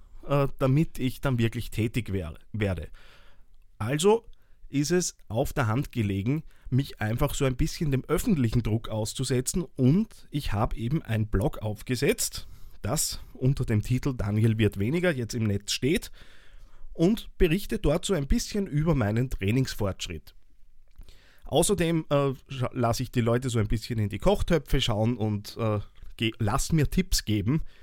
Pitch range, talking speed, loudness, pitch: 110-145 Hz, 140 wpm, -27 LUFS, 125 Hz